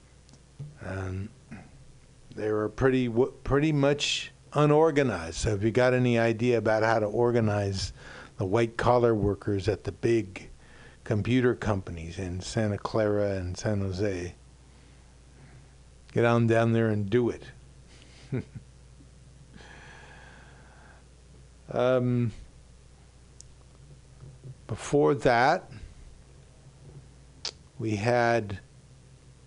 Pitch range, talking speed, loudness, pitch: 90-125 Hz, 95 wpm, -27 LUFS, 110 Hz